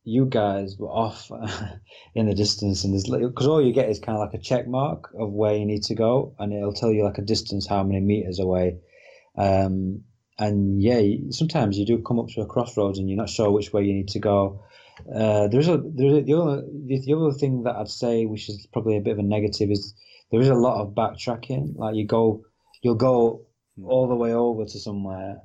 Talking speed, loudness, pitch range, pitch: 225 wpm, -23 LUFS, 100-120 Hz, 110 Hz